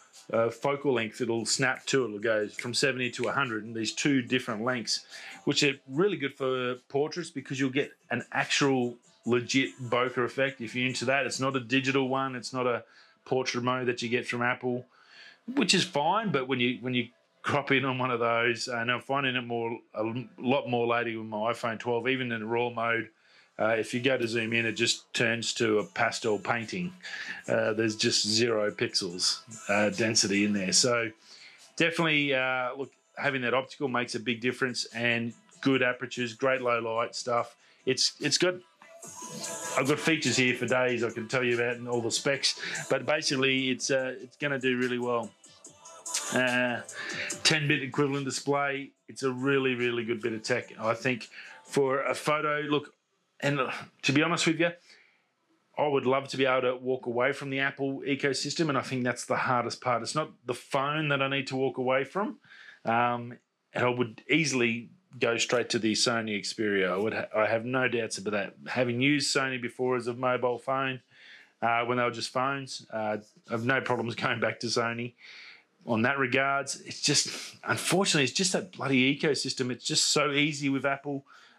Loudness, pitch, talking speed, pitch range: -28 LUFS, 125 Hz, 195 wpm, 120-135 Hz